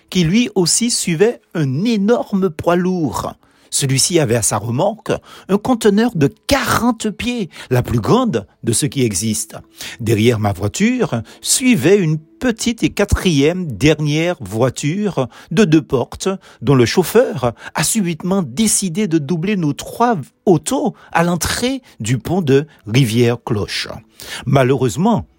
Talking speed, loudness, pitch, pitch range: 130 wpm, -16 LUFS, 170 Hz, 130-210 Hz